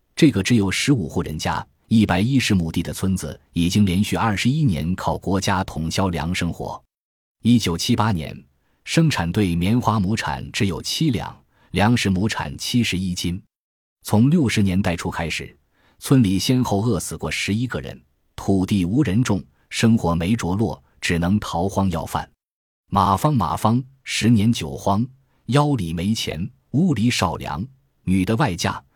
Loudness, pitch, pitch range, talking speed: -21 LUFS, 100 Hz, 90-120 Hz, 235 characters per minute